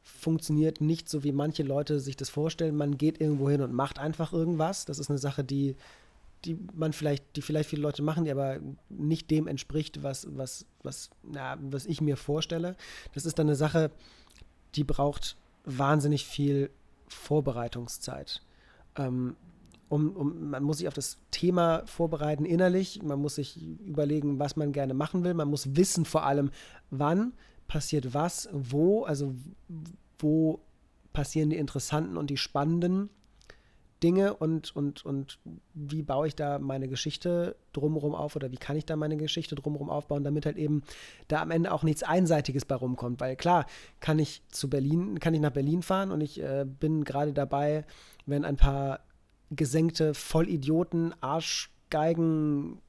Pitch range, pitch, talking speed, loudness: 140-160 Hz, 150 Hz, 165 wpm, -30 LUFS